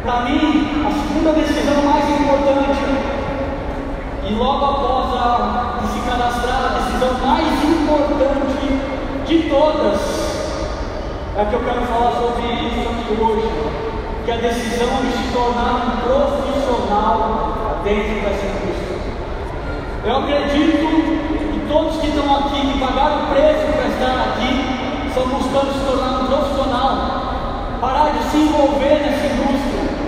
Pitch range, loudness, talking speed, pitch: 245-290 Hz, -18 LUFS, 130 wpm, 275 Hz